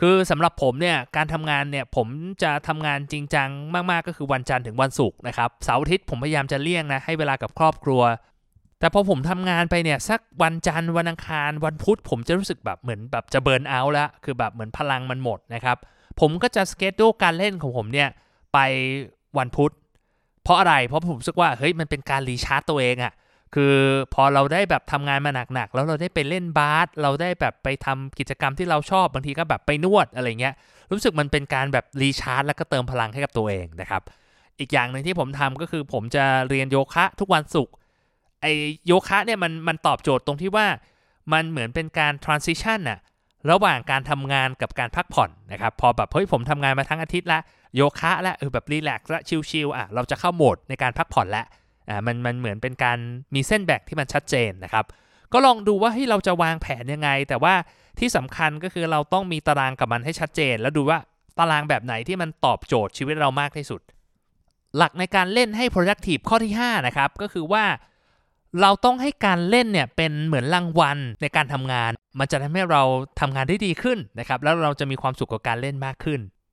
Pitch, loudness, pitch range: 145 Hz, -22 LUFS, 130-170 Hz